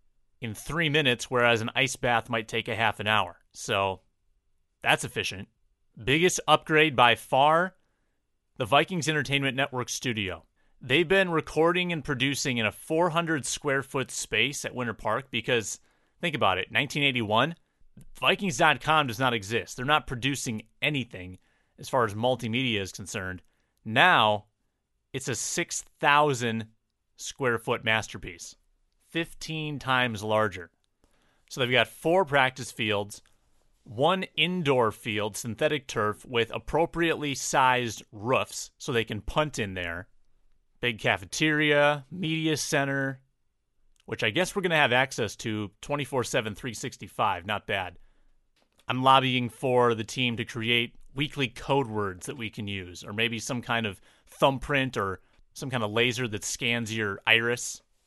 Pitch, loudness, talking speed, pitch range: 125 Hz, -26 LUFS, 140 wpm, 110-145 Hz